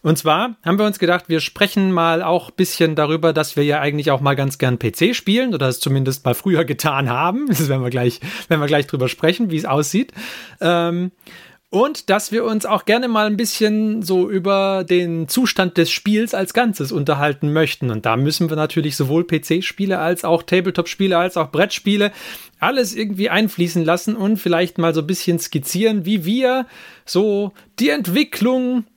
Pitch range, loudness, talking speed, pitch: 155-210 Hz, -18 LUFS, 185 wpm, 175 Hz